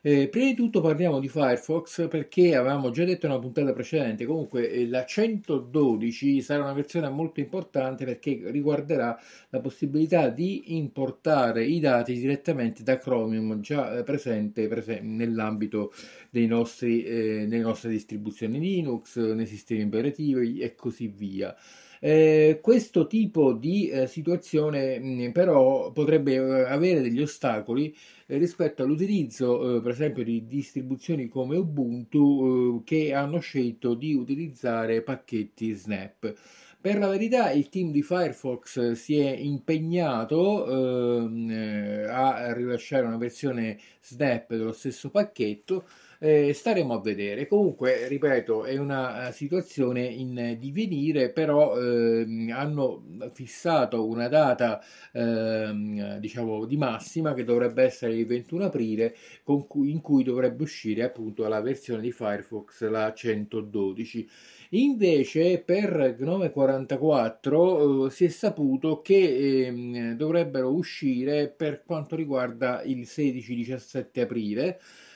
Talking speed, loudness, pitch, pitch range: 125 wpm, -26 LUFS, 130 Hz, 115-155 Hz